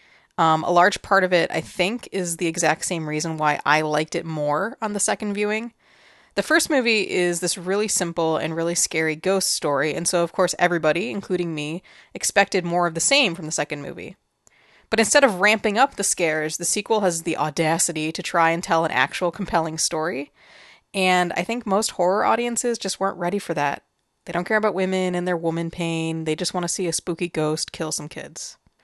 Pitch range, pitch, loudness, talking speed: 160-195 Hz, 175 Hz, -22 LUFS, 210 wpm